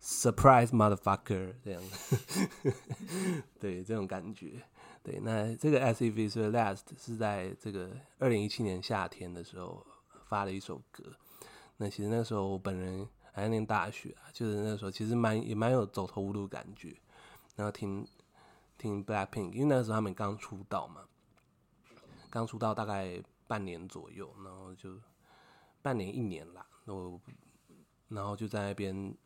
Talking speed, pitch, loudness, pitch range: 285 characters per minute, 105 Hz, -34 LUFS, 95-115 Hz